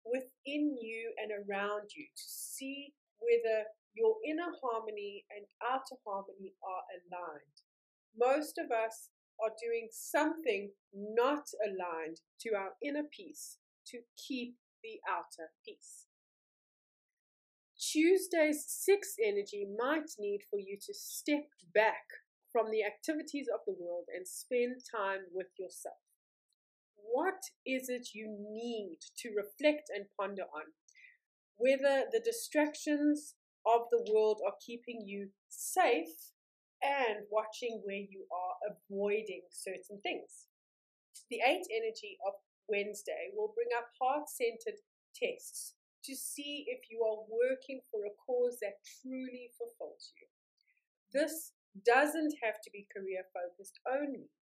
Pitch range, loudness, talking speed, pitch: 205-340 Hz, -37 LUFS, 125 wpm, 250 Hz